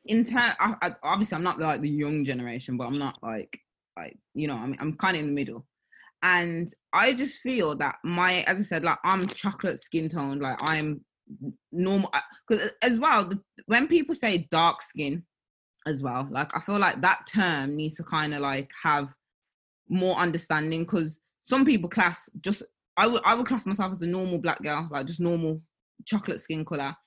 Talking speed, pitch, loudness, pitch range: 200 wpm, 170 Hz, -27 LUFS, 150-200 Hz